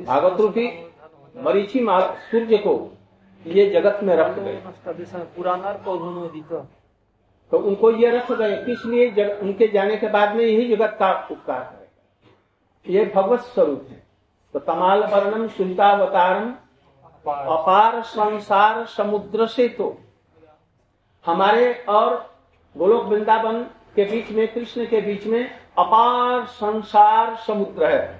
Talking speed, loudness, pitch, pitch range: 115 wpm, -20 LUFS, 210 Hz, 185-230 Hz